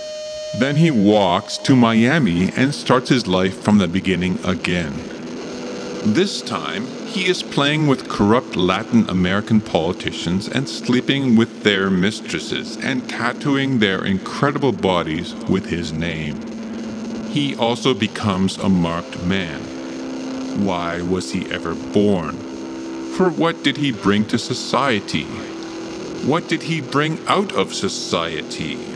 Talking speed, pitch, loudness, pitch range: 125 wpm, 100 Hz, -19 LUFS, 85-130 Hz